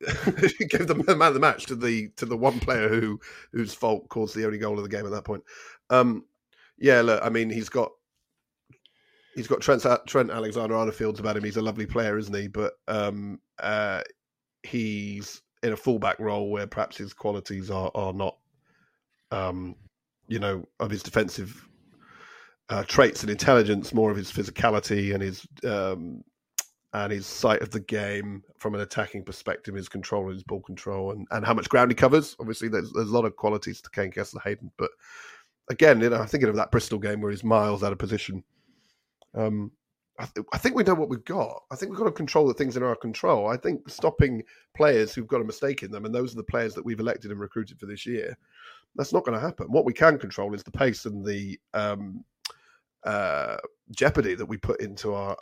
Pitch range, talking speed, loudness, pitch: 100-120 Hz, 210 wpm, -26 LUFS, 110 Hz